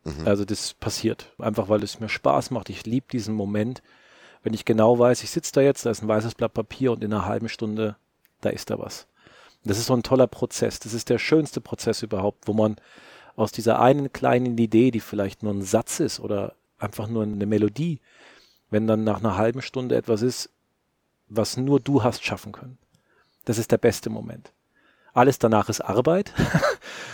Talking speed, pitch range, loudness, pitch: 195 wpm, 105-125 Hz, -24 LUFS, 115 Hz